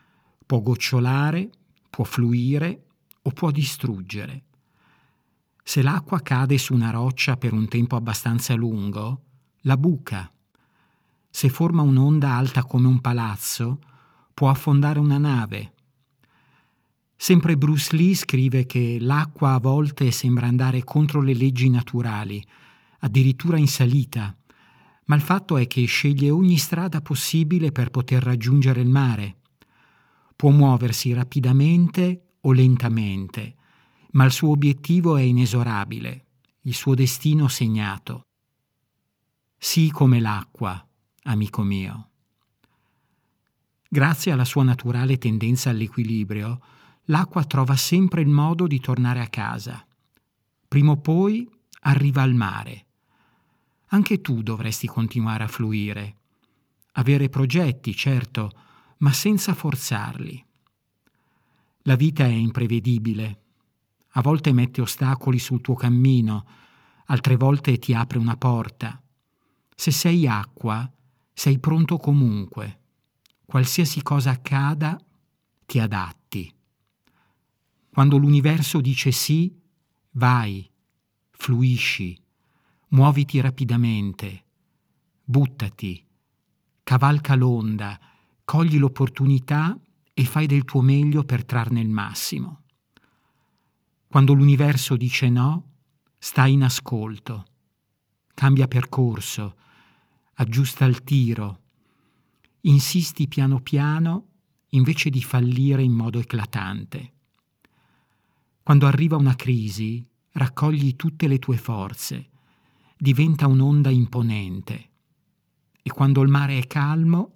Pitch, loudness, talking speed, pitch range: 130 Hz, -21 LUFS, 105 wpm, 120-145 Hz